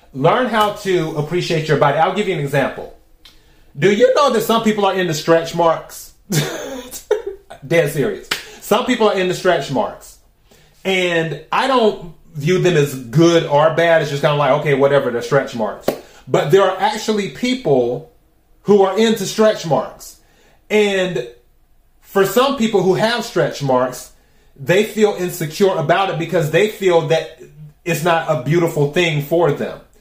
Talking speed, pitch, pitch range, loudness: 165 wpm, 175 Hz, 155-205 Hz, -16 LUFS